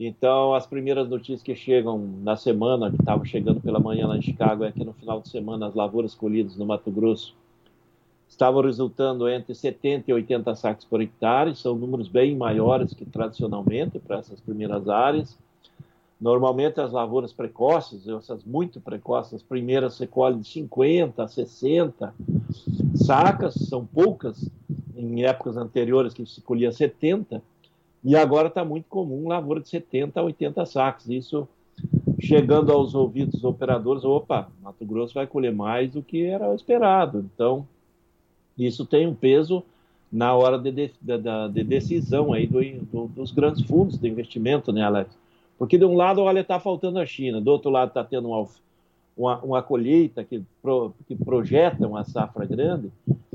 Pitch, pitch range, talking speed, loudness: 130 Hz, 115-145 Hz, 165 wpm, -23 LUFS